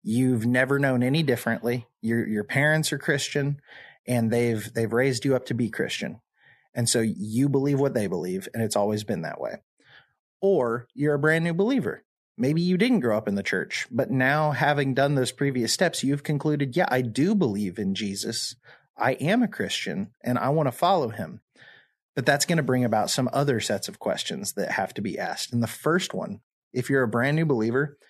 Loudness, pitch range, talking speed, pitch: -25 LUFS, 120-150 Hz, 205 wpm, 130 Hz